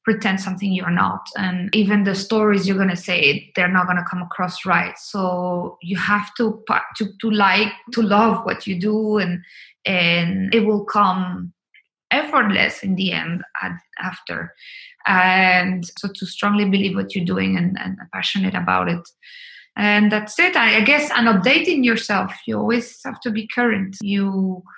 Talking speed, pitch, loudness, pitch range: 170 wpm, 195 Hz, -19 LUFS, 185-215 Hz